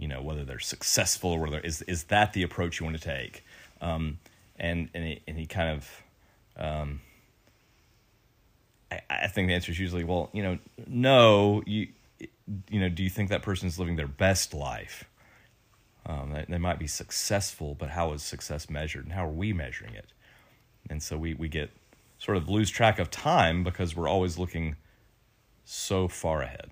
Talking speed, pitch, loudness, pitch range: 190 wpm, 90 Hz, -29 LUFS, 80-105 Hz